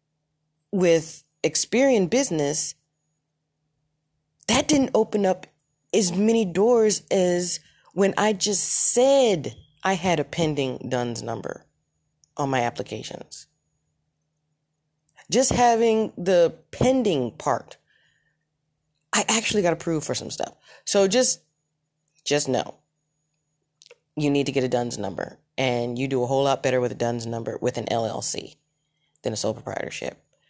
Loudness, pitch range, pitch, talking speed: -23 LUFS, 145-195 Hz, 150 Hz, 130 wpm